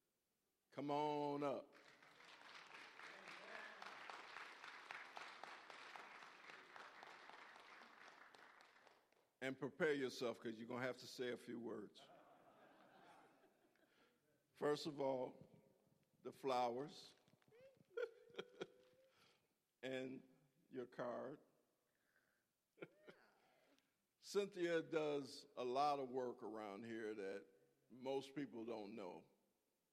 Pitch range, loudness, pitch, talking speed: 125-150 Hz, -49 LUFS, 135 Hz, 75 wpm